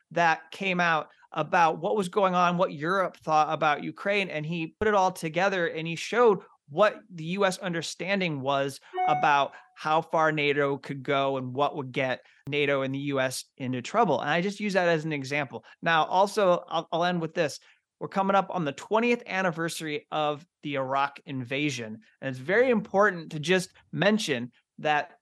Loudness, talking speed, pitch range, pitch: -27 LUFS, 185 wpm, 145-190 Hz, 165 Hz